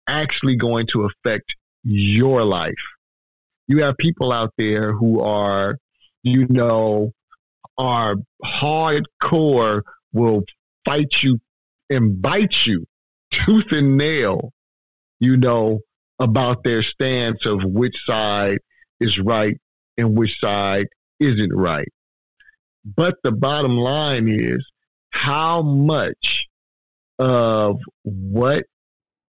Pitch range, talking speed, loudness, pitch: 105-135 Hz, 100 wpm, -19 LUFS, 115 Hz